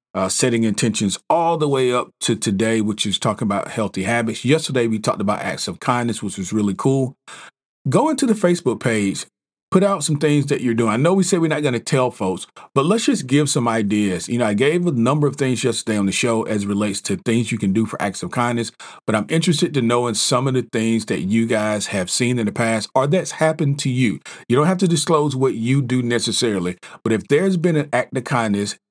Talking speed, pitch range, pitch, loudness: 245 wpm, 110-145 Hz, 120 Hz, -19 LUFS